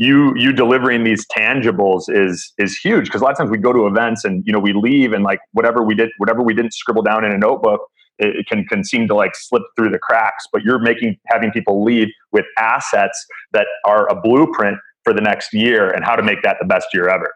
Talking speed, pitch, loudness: 245 wpm, 115 Hz, -15 LUFS